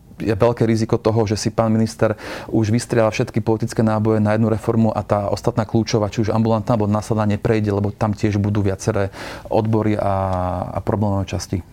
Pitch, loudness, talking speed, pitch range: 110 Hz, -19 LUFS, 180 wpm, 105-115 Hz